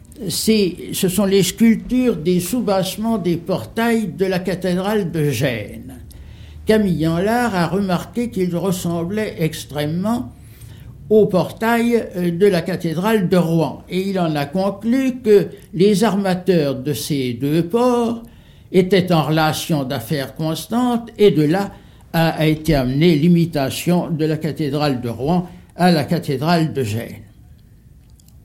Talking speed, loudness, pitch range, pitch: 130 wpm, -18 LUFS, 155-205 Hz, 175 Hz